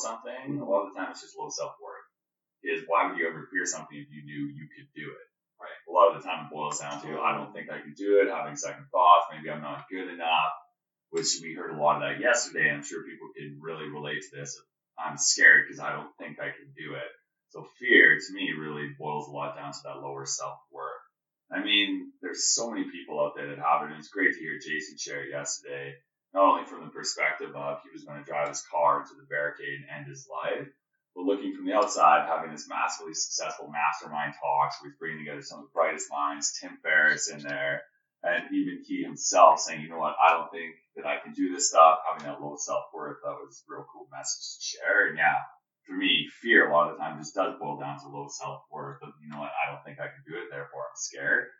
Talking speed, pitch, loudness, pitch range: 250 wpm, 75 Hz, -27 LUFS, 75-85 Hz